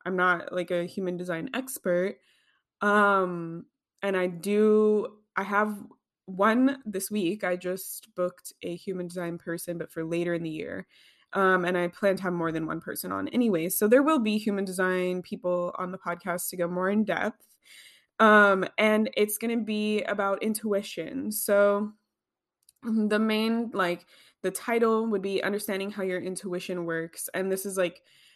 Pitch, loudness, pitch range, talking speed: 190 Hz, -27 LUFS, 180-215 Hz, 170 wpm